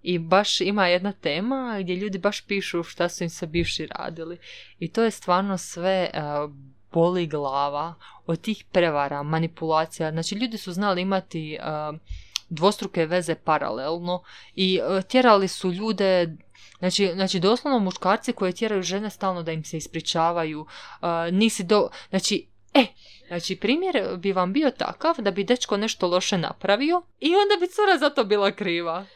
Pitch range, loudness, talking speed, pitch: 165-205 Hz, -24 LUFS, 165 wpm, 185 Hz